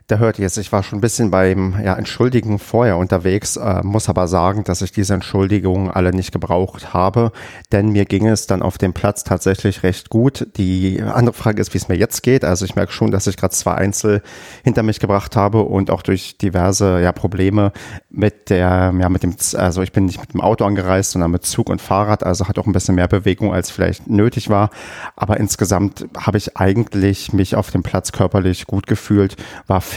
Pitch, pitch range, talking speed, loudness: 100 Hz, 95-105 Hz, 210 wpm, -17 LUFS